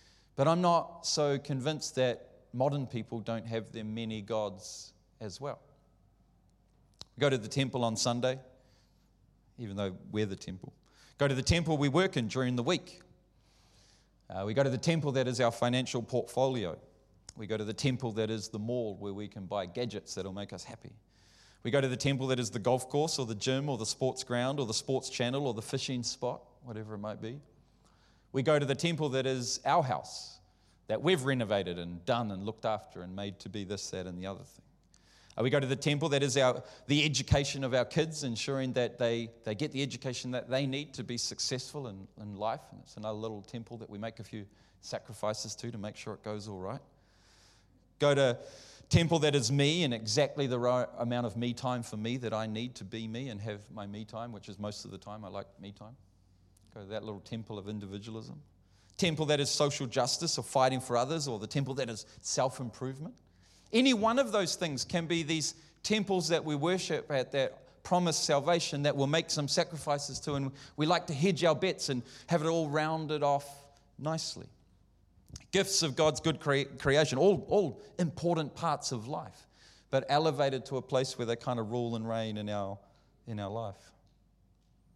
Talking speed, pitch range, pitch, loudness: 210 wpm, 110-140 Hz, 125 Hz, -32 LUFS